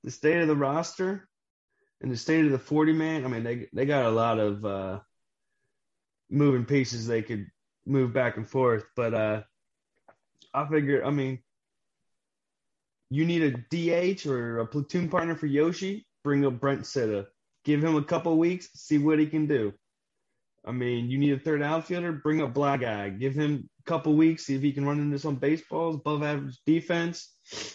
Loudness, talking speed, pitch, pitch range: -27 LUFS, 185 wpm, 145 Hz, 125-160 Hz